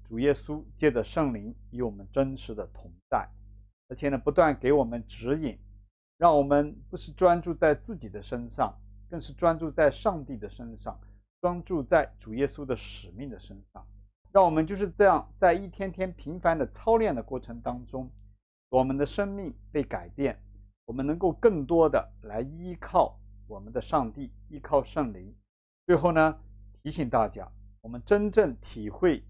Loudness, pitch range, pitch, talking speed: -27 LUFS, 100-155 Hz, 130 Hz, 250 characters per minute